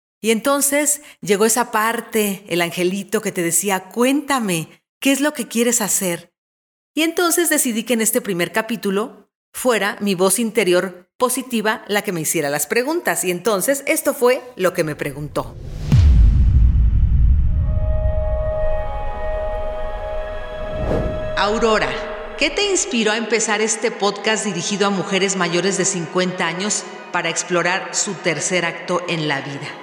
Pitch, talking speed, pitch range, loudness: 195 Hz, 135 wpm, 165-225 Hz, -19 LUFS